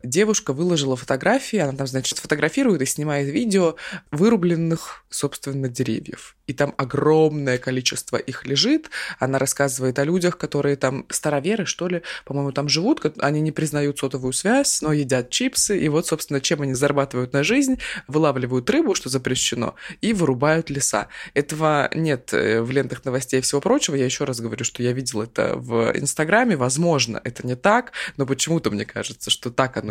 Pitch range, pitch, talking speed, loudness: 130-160 Hz, 140 Hz, 165 wpm, -21 LUFS